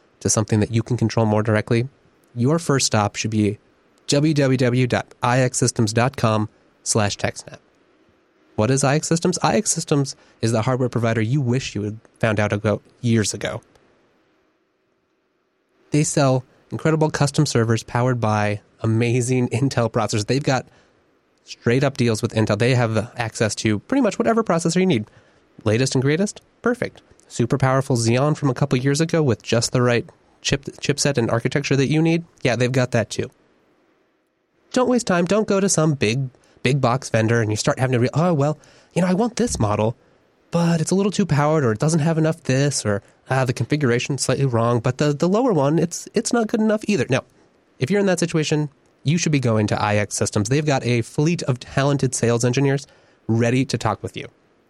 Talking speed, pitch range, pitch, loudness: 185 wpm, 115-155 Hz, 130 Hz, -20 LUFS